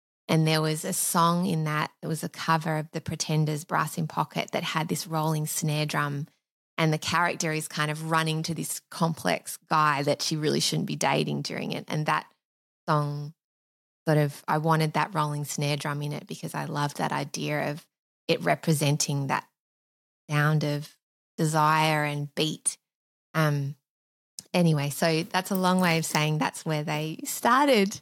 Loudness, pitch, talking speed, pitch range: -27 LUFS, 155 Hz, 175 wpm, 145-160 Hz